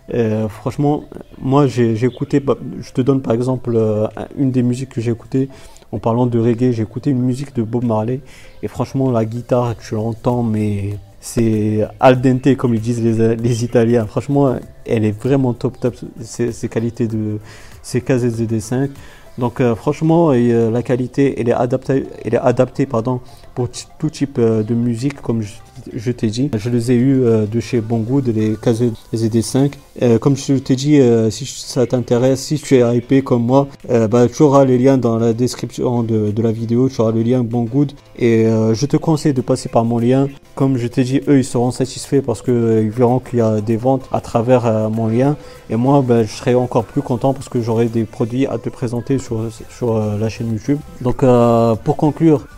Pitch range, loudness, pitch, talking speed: 115-130 Hz, -16 LUFS, 120 Hz, 210 wpm